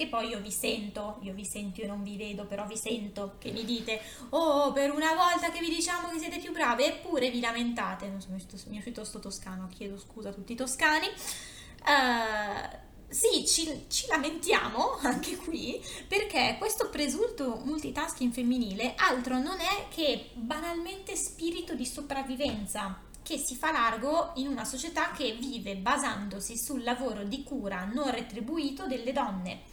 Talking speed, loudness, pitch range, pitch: 165 wpm, -31 LUFS, 215-315 Hz, 255 Hz